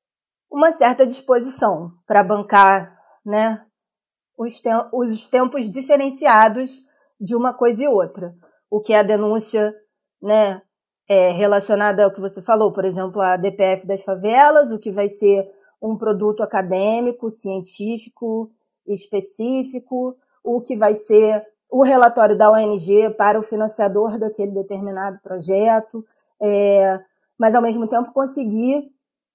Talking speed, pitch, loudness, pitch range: 130 wpm, 215 Hz, -18 LUFS, 200-240 Hz